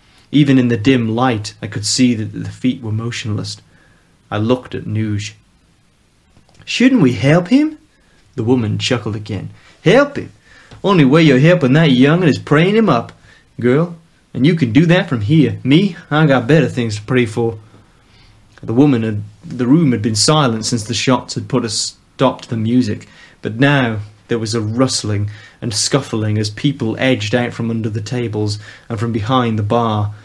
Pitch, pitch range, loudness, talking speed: 120 Hz, 105-135 Hz, -15 LUFS, 185 wpm